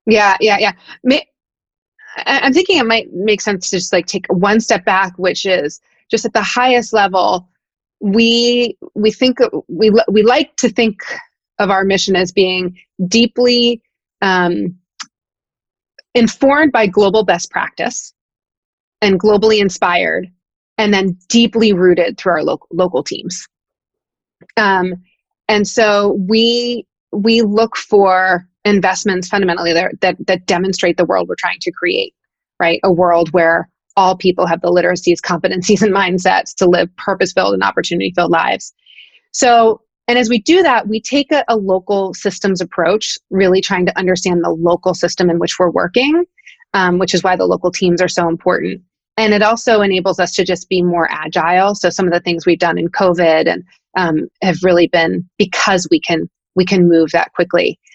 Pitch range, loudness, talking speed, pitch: 180-225 Hz, -13 LUFS, 165 wpm, 195 Hz